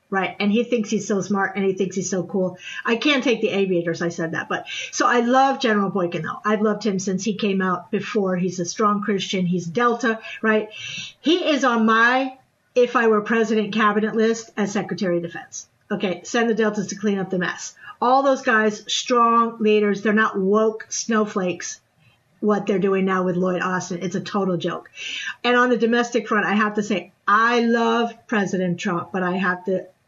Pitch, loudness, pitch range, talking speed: 210 Hz, -21 LUFS, 185-230 Hz, 205 wpm